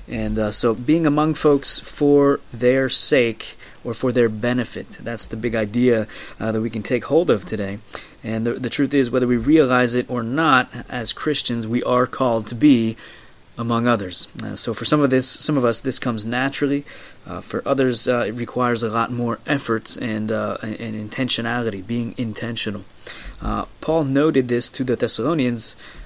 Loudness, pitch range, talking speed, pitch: -20 LUFS, 110-130 Hz, 180 wpm, 120 Hz